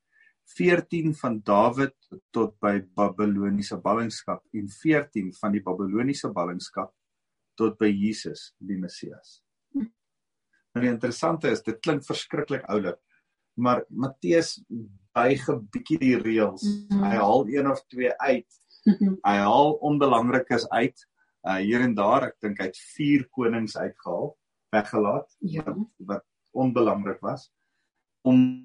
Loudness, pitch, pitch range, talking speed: -25 LUFS, 125 Hz, 105-160 Hz, 120 wpm